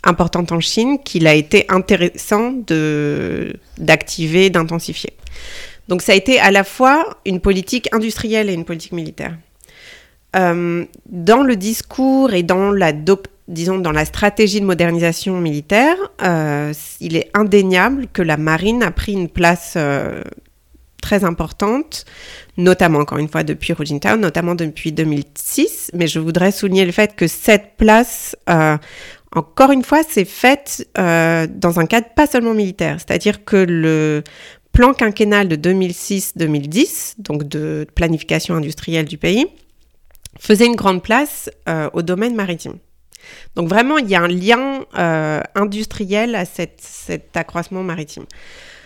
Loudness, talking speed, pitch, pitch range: -15 LUFS, 145 wpm, 185 Hz, 165-220 Hz